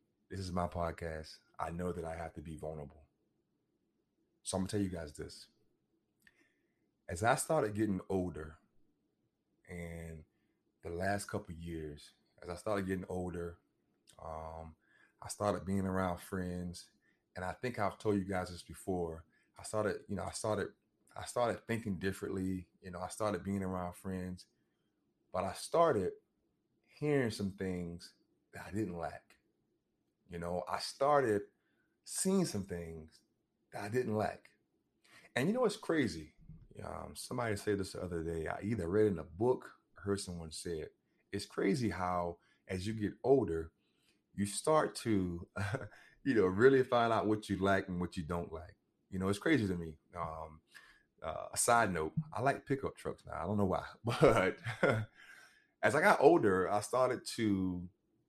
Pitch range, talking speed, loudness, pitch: 85-105 Hz, 165 wpm, -36 LUFS, 95 Hz